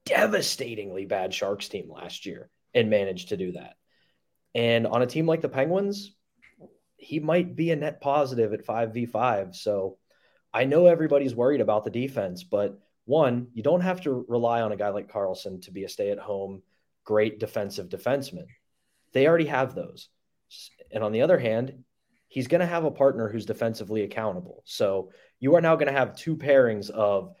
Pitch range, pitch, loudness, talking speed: 110-160 Hz, 125 Hz, -26 LUFS, 180 wpm